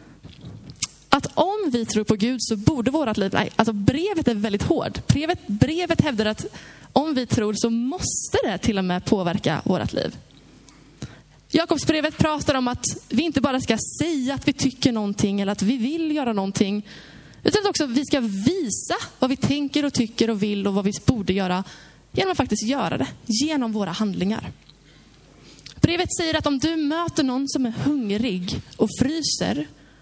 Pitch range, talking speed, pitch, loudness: 215-295 Hz, 180 wpm, 250 Hz, -22 LUFS